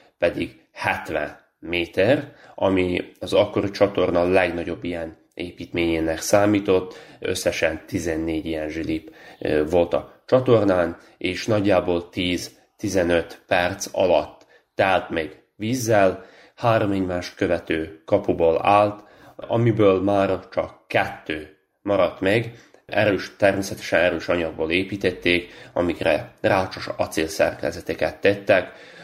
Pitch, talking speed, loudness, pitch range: 90 Hz, 95 wpm, -22 LUFS, 85-100 Hz